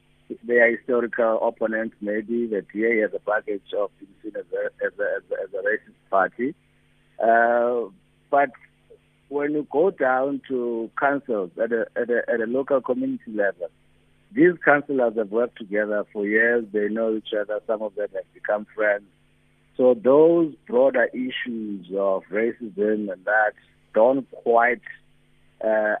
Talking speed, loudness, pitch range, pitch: 155 wpm, -23 LUFS, 110-165 Hz, 120 Hz